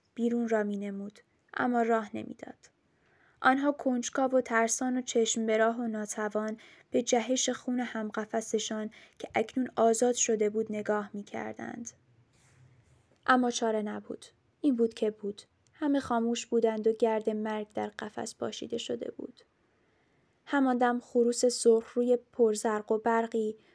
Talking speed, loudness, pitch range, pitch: 140 wpm, -30 LUFS, 215-245 Hz, 225 Hz